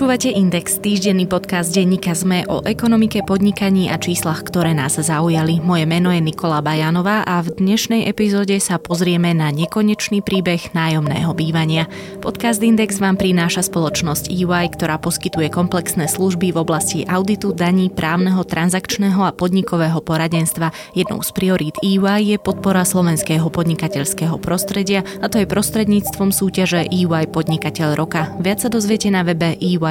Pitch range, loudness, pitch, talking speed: 165-195 Hz, -17 LUFS, 180 Hz, 145 wpm